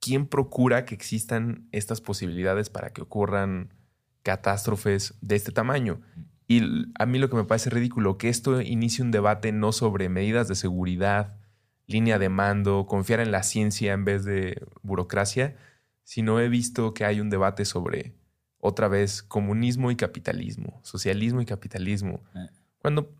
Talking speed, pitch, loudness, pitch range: 155 wpm, 110 Hz, -26 LUFS, 100-120 Hz